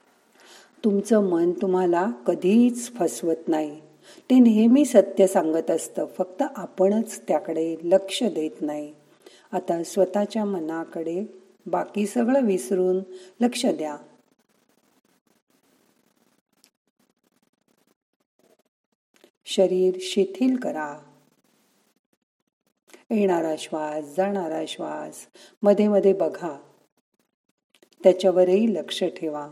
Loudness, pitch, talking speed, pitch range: -23 LUFS, 190 Hz, 75 wpm, 170-215 Hz